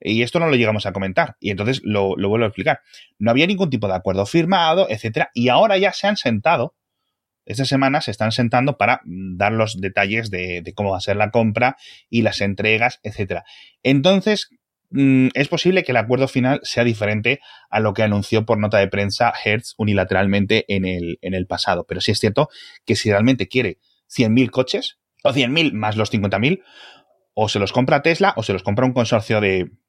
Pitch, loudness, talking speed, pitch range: 110 Hz, -19 LUFS, 205 wpm, 100-130 Hz